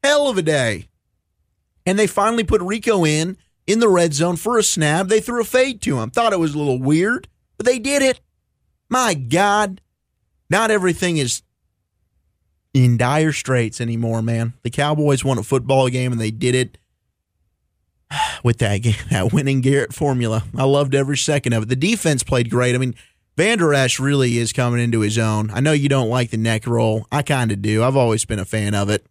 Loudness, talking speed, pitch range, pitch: -18 LUFS, 200 wpm, 115-170 Hz, 130 Hz